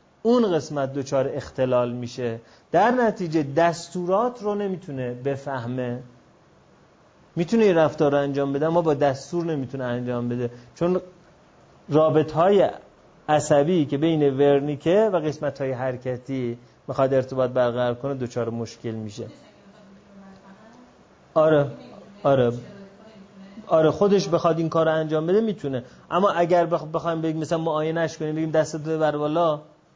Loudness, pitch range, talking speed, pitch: -23 LUFS, 130-170 Hz, 125 wpm, 155 Hz